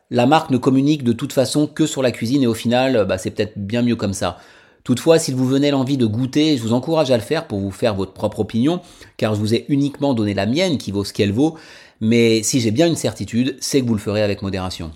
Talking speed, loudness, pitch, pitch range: 265 wpm, -18 LUFS, 120 Hz, 105-140 Hz